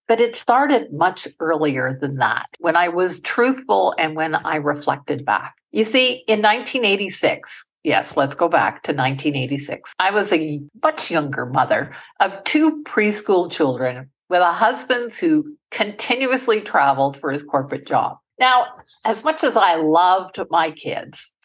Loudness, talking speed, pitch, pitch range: -19 LUFS, 150 wpm, 185 Hz, 155-240 Hz